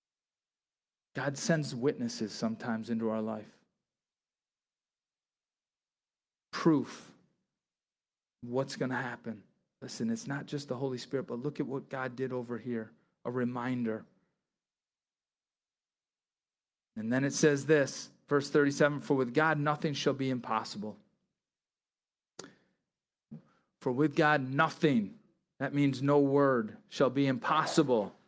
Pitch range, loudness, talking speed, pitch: 120-145 Hz, -32 LUFS, 115 wpm, 135 Hz